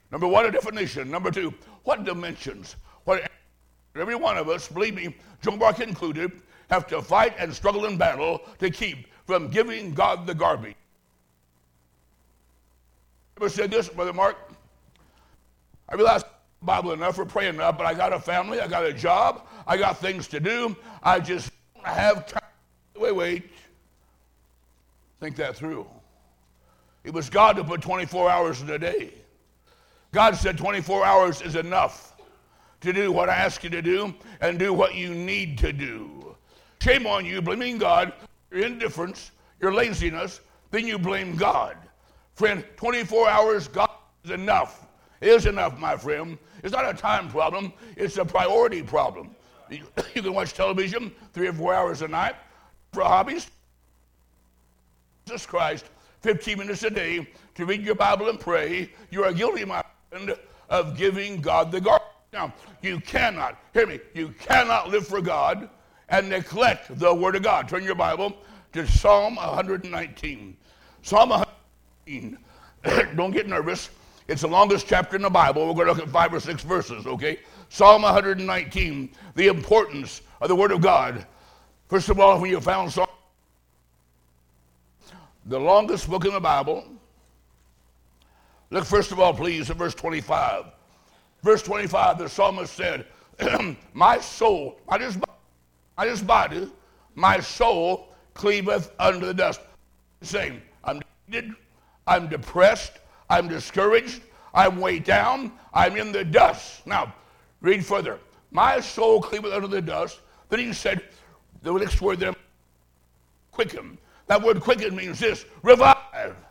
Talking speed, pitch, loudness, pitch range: 150 wpm, 185 Hz, -23 LUFS, 135-205 Hz